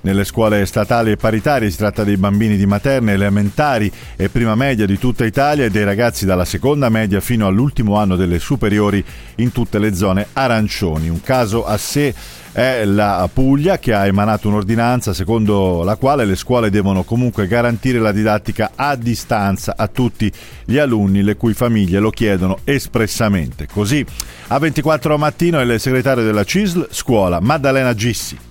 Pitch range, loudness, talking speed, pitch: 100-125 Hz, -16 LUFS, 165 wpm, 110 Hz